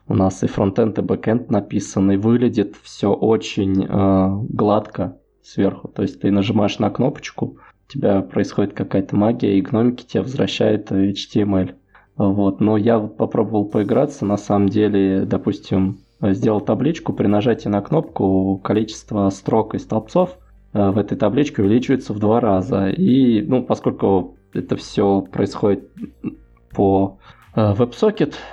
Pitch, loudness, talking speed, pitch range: 105 Hz, -19 LUFS, 130 wpm, 95-110 Hz